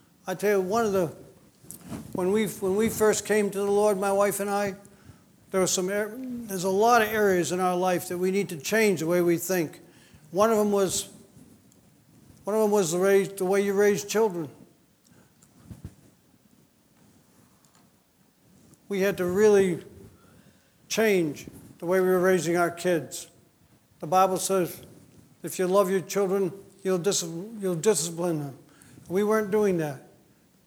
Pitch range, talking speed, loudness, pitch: 180-205 Hz, 160 wpm, -25 LUFS, 190 Hz